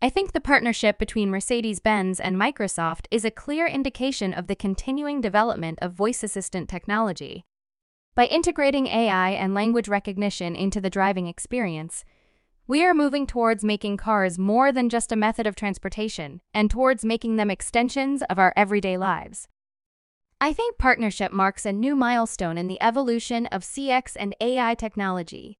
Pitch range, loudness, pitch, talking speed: 195-245 Hz, -24 LUFS, 215 Hz, 160 wpm